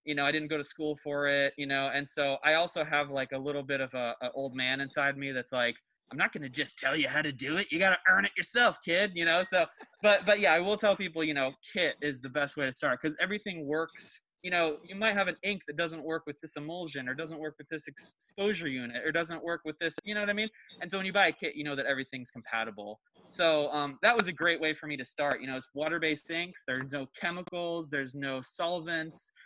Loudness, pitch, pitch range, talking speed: -30 LUFS, 155 Hz, 140-170 Hz, 270 wpm